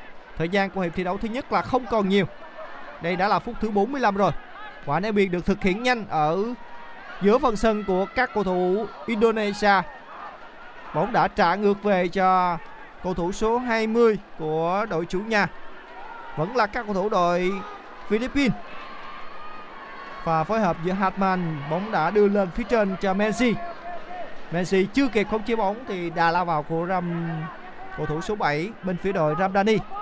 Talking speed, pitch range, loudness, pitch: 180 wpm, 180-220 Hz, -24 LUFS, 195 Hz